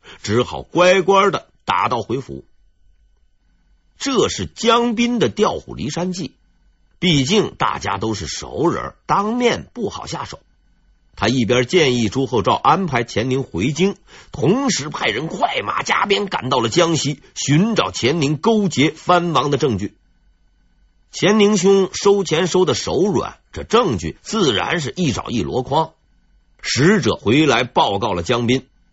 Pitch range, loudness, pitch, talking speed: 125-195 Hz, -18 LUFS, 160 Hz, 205 characters per minute